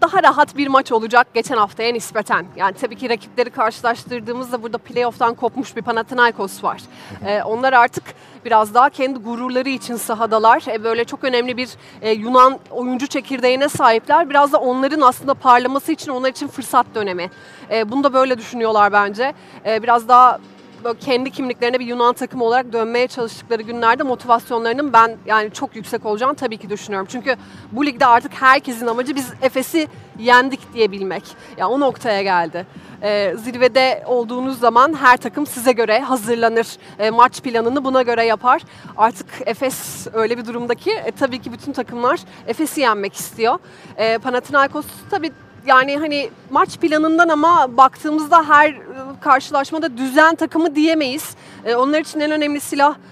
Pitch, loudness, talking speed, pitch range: 250 Hz, -17 LUFS, 150 wpm, 230-270 Hz